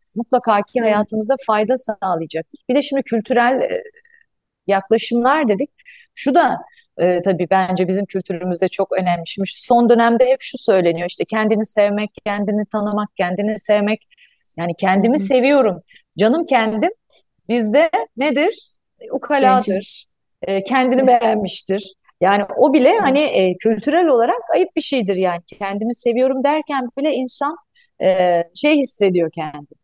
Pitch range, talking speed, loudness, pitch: 195-280 Hz, 120 wpm, -17 LUFS, 230 Hz